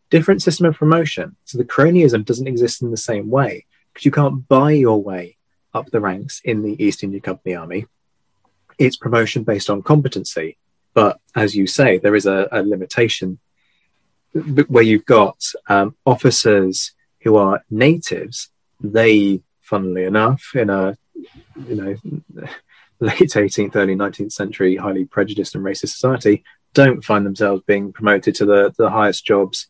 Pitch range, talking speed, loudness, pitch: 100-130 Hz, 155 wpm, -16 LUFS, 105 Hz